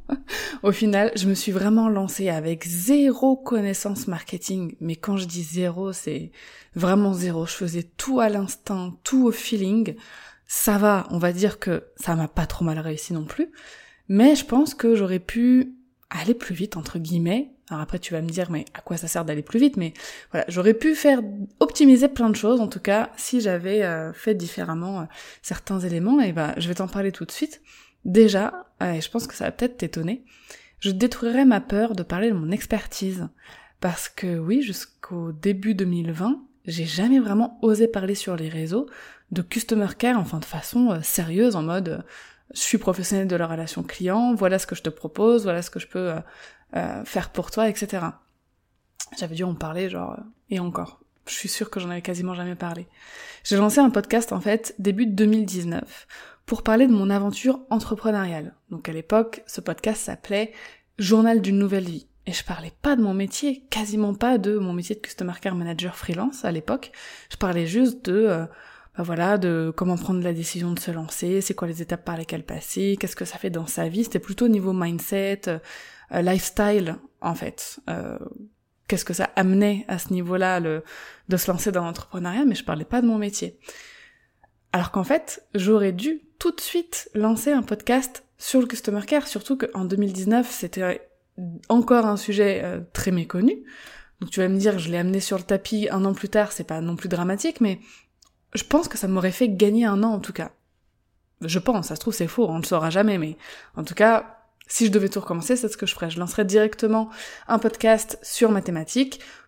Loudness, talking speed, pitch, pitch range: -23 LUFS, 200 wpm, 200 Hz, 180-230 Hz